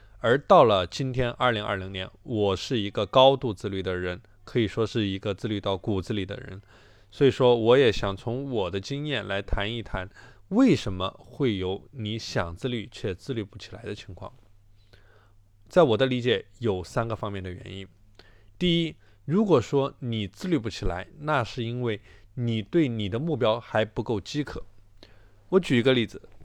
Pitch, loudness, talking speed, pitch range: 110 Hz, -26 LUFS, 255 characters per minute, 100-125 Hz